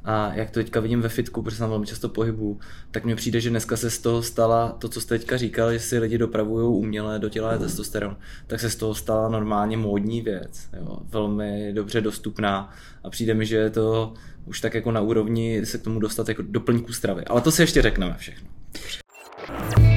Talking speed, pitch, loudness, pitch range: 205 wpm, 110 Hz, -24 LUFS, 105-115 Hz